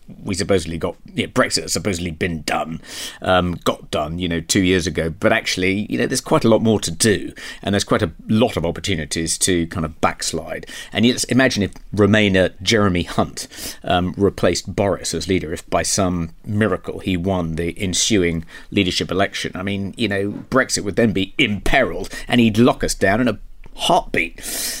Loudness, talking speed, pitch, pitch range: -19 LUFS, 190 wpm, 95 Hz, 85-105 Hz